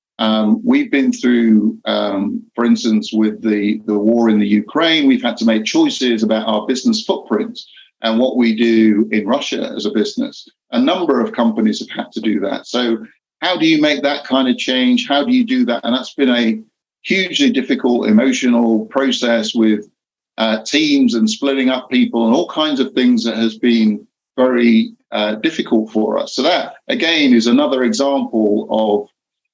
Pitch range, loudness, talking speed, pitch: 110-145 Hz, -15 LUFS, 185 wpm, 120 Hz